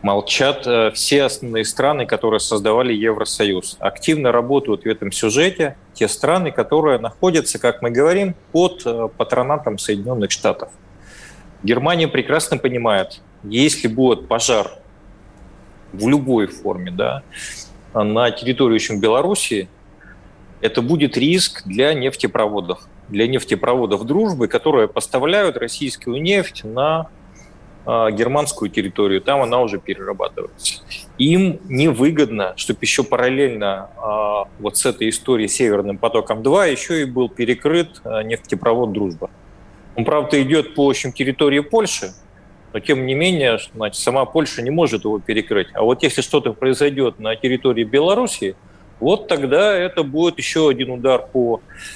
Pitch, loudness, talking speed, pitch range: 125 Hz, -18 LUFS, 125 wpm, 110-150 Hz